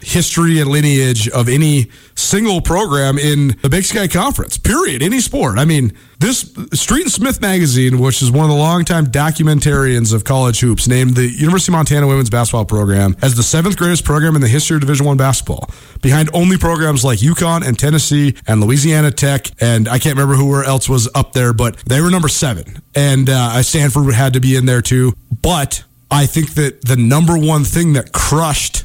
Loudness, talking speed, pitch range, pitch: -13 LUFS, 200 wpm, 125-155 Hz, 140 Hz